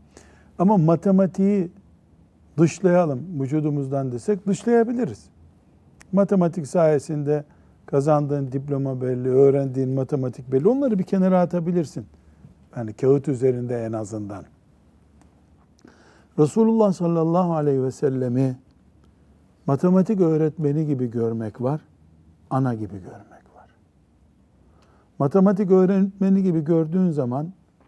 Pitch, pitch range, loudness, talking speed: 145 Hz, 120-180 Hz, -21 LUFS, 90 wpm